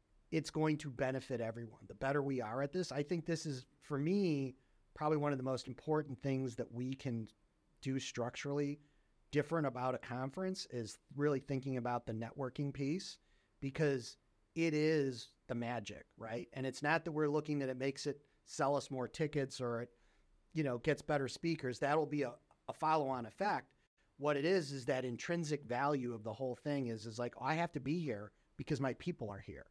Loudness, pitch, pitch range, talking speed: -39 LUFS, 135 Hz, 125-150 Hz, 200 wpm